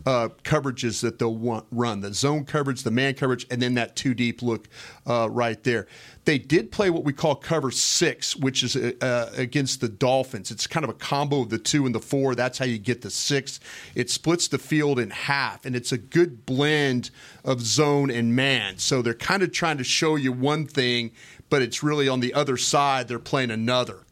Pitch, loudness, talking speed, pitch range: 130 Hz, -24 LUFS, 215 wpm, 120-140 Hz